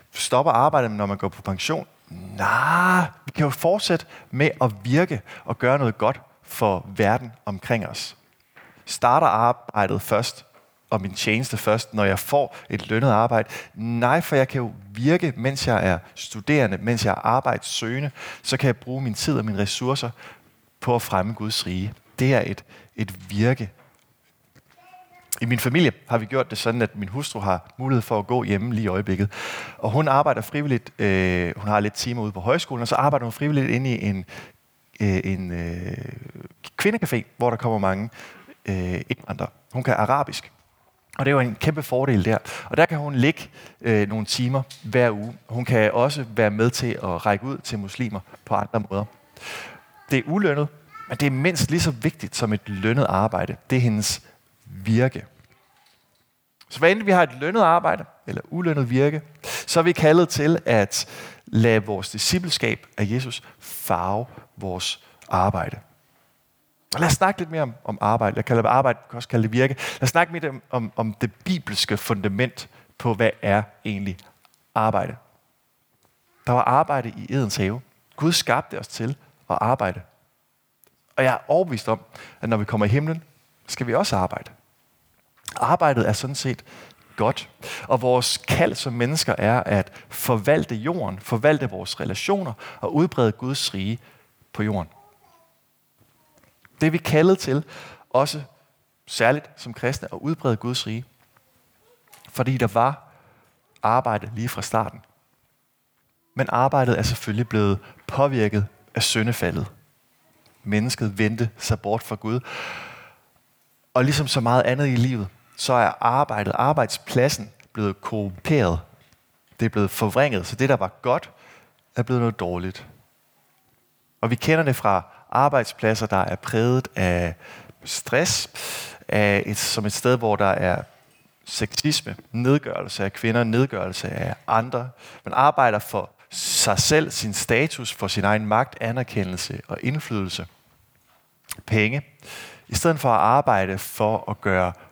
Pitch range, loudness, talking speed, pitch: 105-135 Hz, -23 LUFS, 160 wpm, 120 Hz